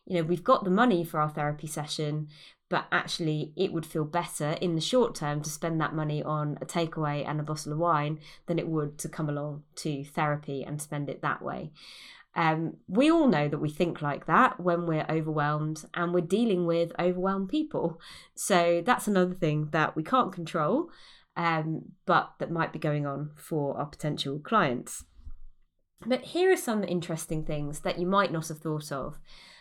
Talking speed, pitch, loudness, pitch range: 195 wpm, 160 Hz, -29 LUFS, 150-175 Hz